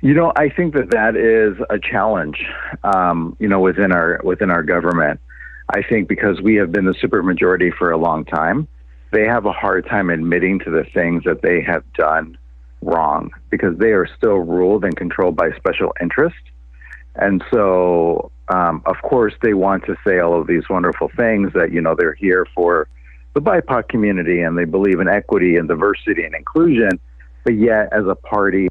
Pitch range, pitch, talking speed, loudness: 80-100 Hz, 90 Hz, 190 wpm, -16 LUFS